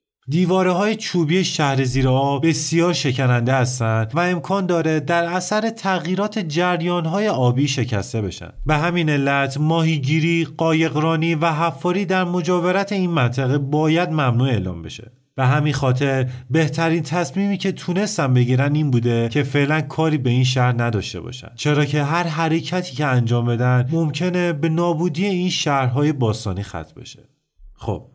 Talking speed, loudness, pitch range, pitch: 145 wpm, -19 LUFS, 130-175 Hz, 155 Hz